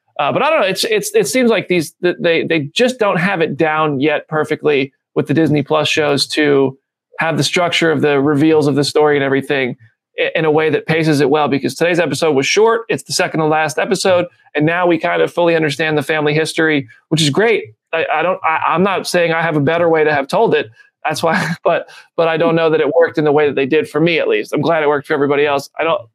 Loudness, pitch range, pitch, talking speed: -15 LUFS, 150-170 Hz, 155 Hz, 260 wpm